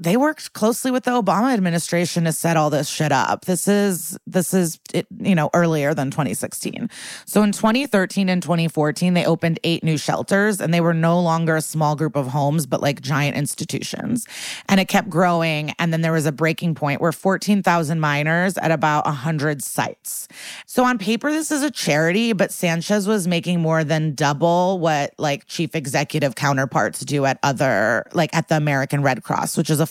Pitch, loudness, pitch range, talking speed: 165 Hz, -20 LUFS, 155-190 Hz, 195 wpm